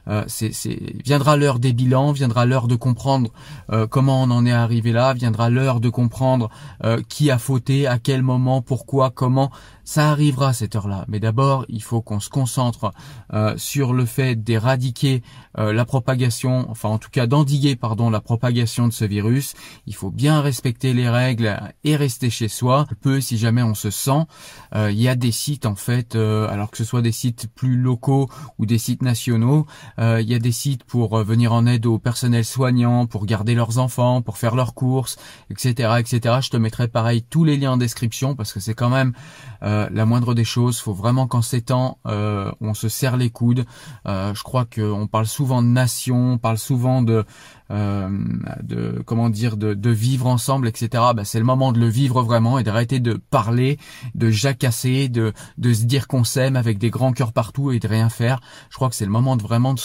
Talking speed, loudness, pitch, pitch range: 215 wpm, -20 LUFS, 120 Hz, 115-130 Hz